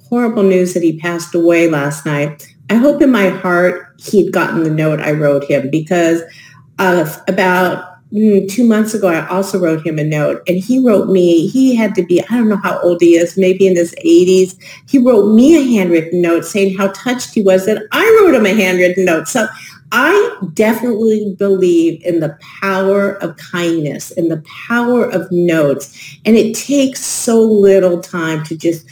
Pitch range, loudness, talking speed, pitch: 165-210 Hz, -12 LUFS, 190 wpm, 185 Hz